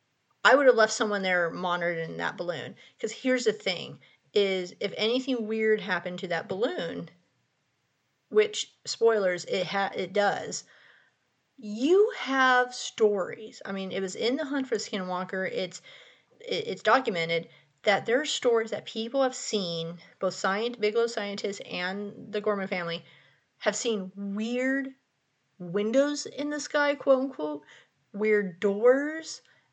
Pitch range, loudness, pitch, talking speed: 190-255 Hz, -28 LUFS, 215 Hz, 145 wpm